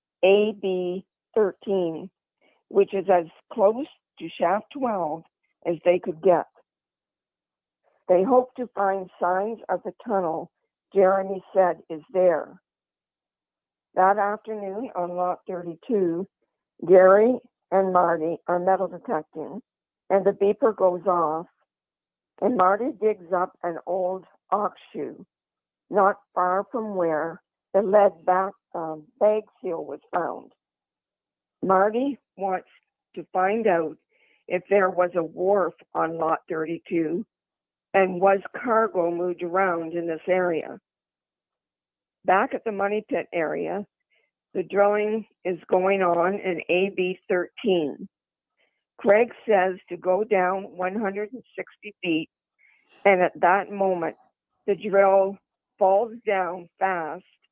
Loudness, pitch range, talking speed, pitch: -24 LUFS, 175-205 Hz, 120 wpm, 190 Hz